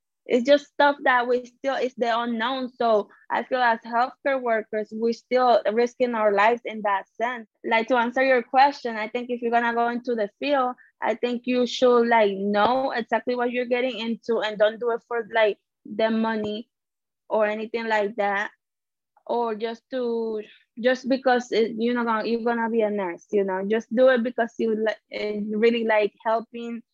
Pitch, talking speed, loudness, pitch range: 235 Hz, 190 wpm, -24 LUFS, 220-250 Hz